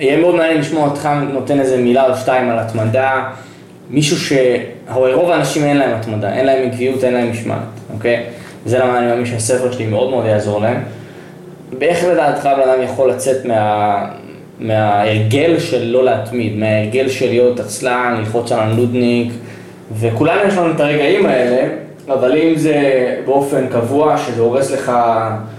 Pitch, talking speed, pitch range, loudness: 125 Hz, 155 wpm, 115-140 Hz, -14 LUFS